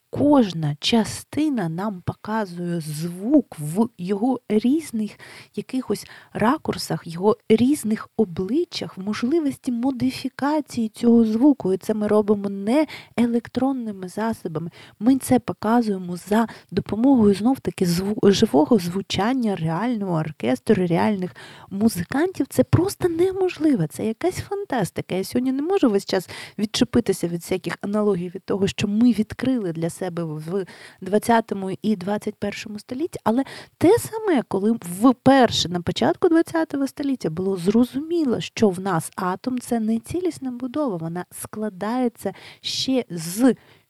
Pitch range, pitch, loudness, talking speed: 185-255 Hz, 215 Hz, -22 LUFS, 125 wpm